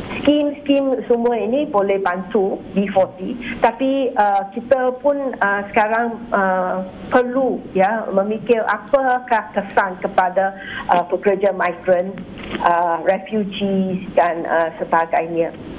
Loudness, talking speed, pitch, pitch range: -19 LUFS, 105 wpm, 200 Hz, 190-245 Hz